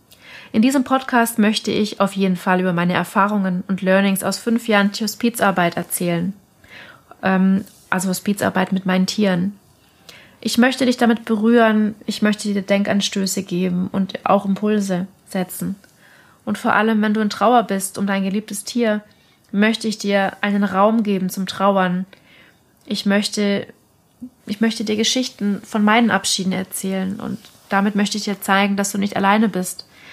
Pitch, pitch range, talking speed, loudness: 200 Hz, 190-215 Hz, 160 wpm, -19 LUFS